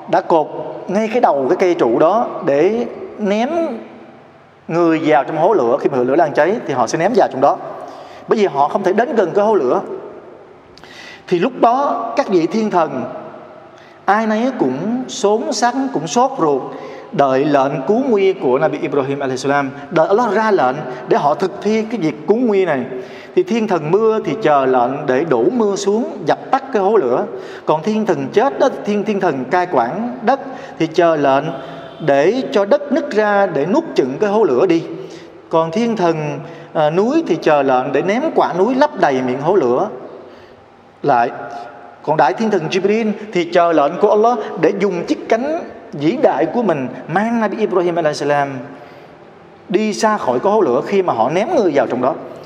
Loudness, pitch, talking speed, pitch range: -16 LUFS, 195 Hz, 195 wpm, 155-220 Hz